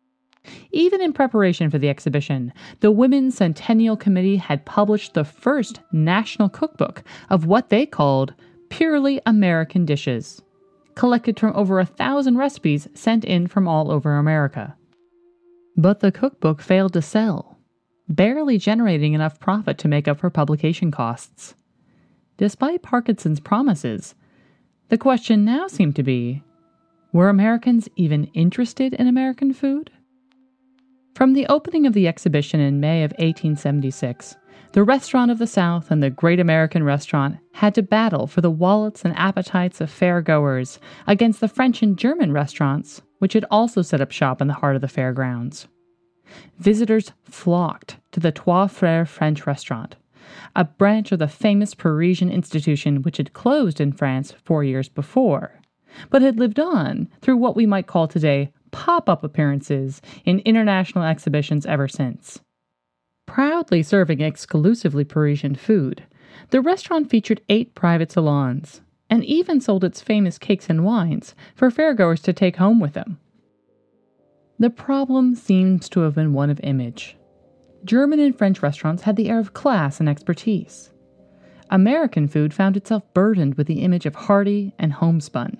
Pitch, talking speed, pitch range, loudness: 185 Hz, 150 wpm, 150-225 Hz, -19 LUFS